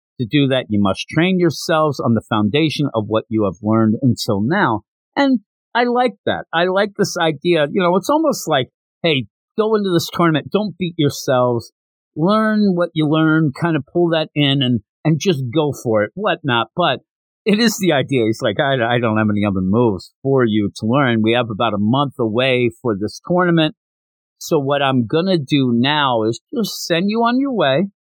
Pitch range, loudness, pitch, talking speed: 115-175 Hz, -17 LUFS, 145 Hz, 200 wpm